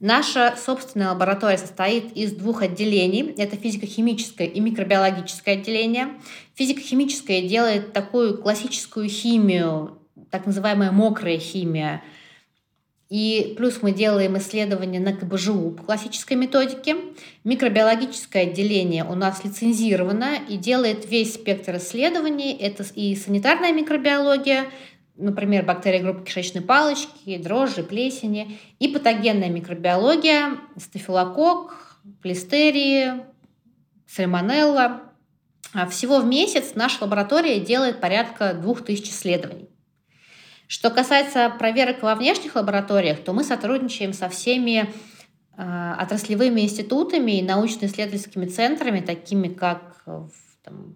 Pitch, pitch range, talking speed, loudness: 210 Hz, 190-250 Hz, 100 wpm, -21 LUFS